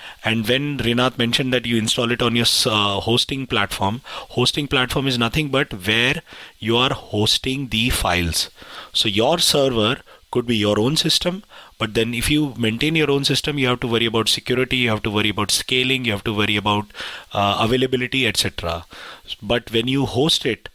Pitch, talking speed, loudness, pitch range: 120 Hz, 190 wpm, -19 LUFS, 110-130 Hz